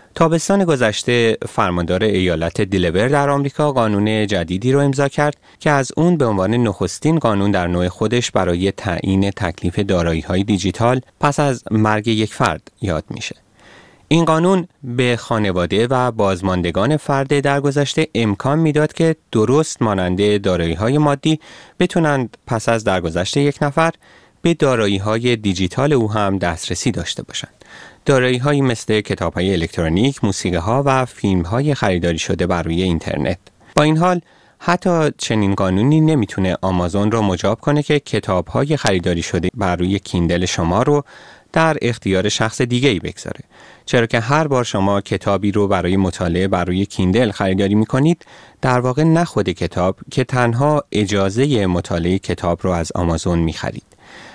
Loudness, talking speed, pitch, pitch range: -17 LUFS, 150 wpm, 110 Hz, 95-140 Hz